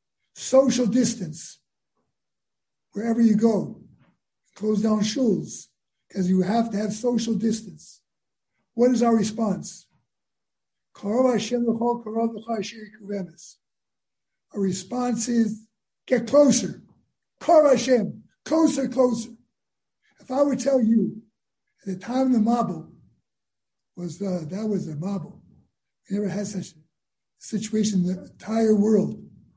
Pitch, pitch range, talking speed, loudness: 220 Hz, 200-245 Hz, 105 wpm, -23 LUFS